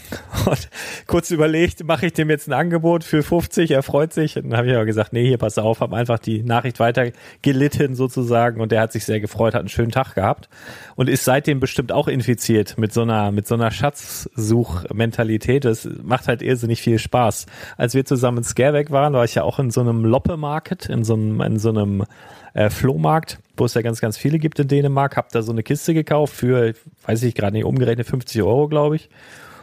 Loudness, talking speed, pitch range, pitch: -19 LUFS, 220 wpm, 115-145 Hz, 125 Hz